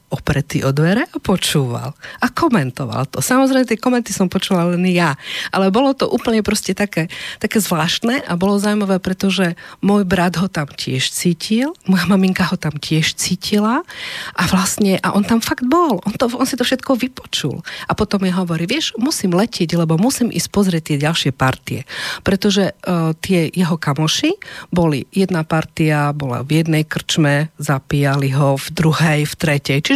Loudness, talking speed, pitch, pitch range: -17 LUFS, 170 wpm, 180 Hz, 155-210 Hz